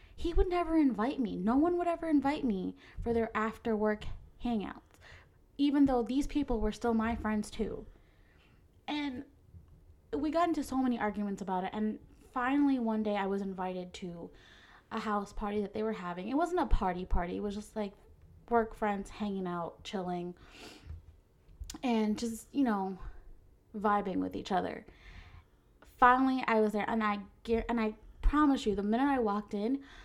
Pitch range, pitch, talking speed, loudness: 185-250 Hz, 215 Hz, 170 wpm, -33 LUFS